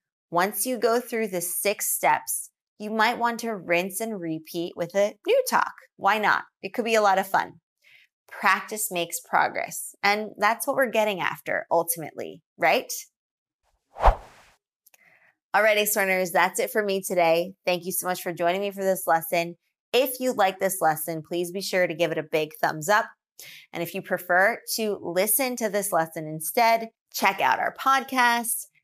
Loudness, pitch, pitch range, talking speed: -24 LUFS, 195 Hz, 170-220 Hz, 175 wpm